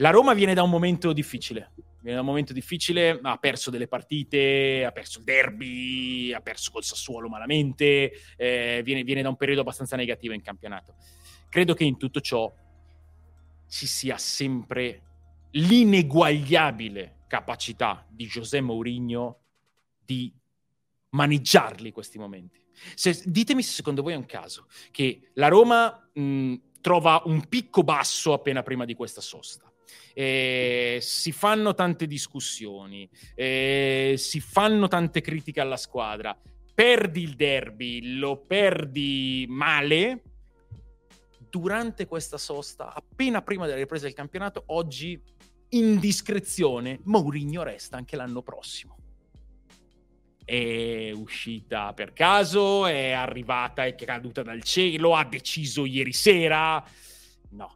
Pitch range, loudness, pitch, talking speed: 120-165 Hz, -24 LUFS, 135 Hz, 125 wpm